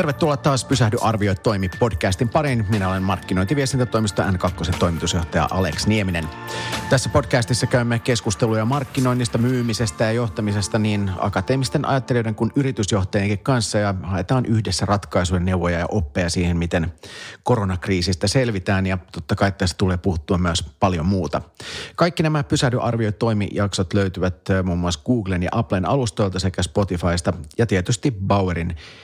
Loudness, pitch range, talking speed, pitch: -21 LUFS, 95-125 Hz, 135 wpm, 105 Hz